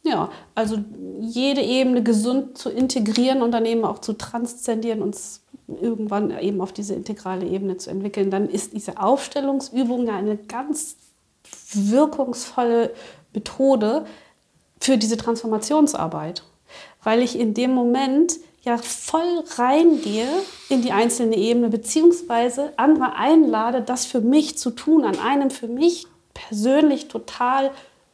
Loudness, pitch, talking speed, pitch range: -21 LUFS, 245 Hz, 130 wpm, 220-275 Hz